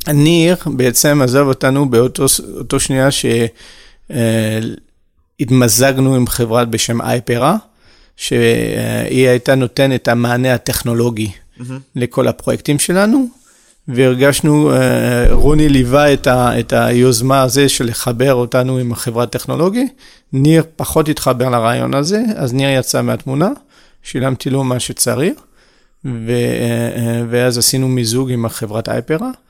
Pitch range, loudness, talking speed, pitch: 120-140 Hz, -14 LUFS, 105 wpm, 130 Hz